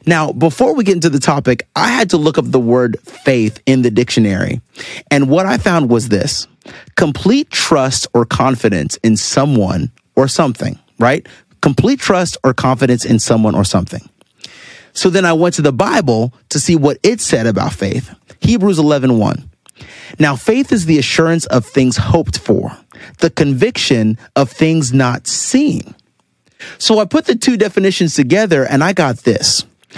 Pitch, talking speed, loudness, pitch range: 140 Hz, 165 wpm, -13 LUFS, 120-175 Hz